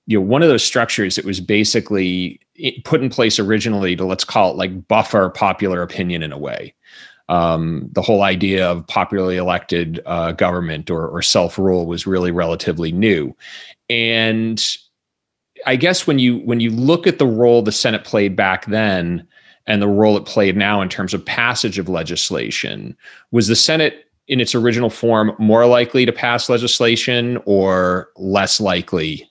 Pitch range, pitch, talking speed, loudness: 90-120 Hz, 105 Hz, 170 wpm, -16 LUFS